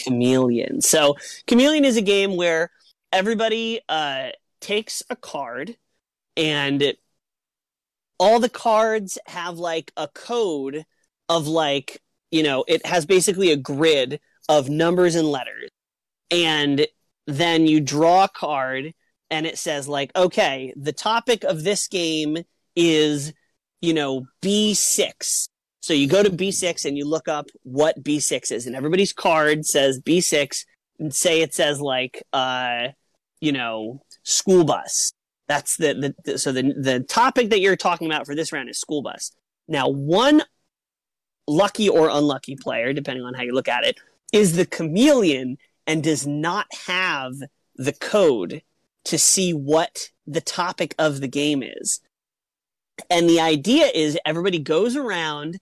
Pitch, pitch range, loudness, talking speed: 160 Hz, 145-190 Hz, -21 LUFS, 150 wpm